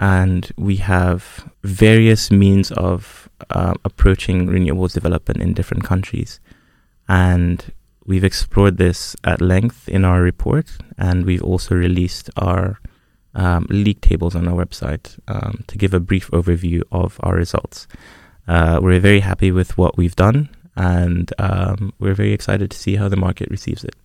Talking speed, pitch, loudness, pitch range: 155 wpm, 95 Hz, -17 LUFS, 90-100 Hz